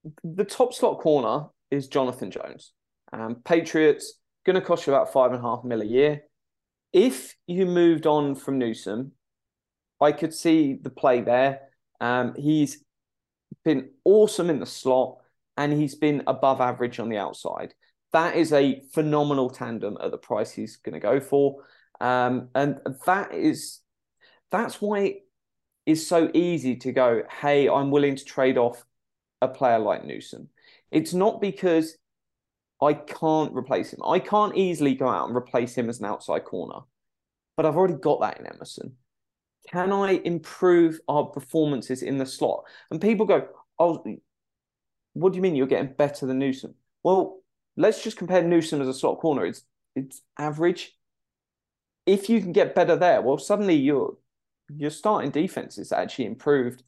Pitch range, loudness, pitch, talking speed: 130-175 Hz, -24 LUFS, 145 Hz, 165 wpm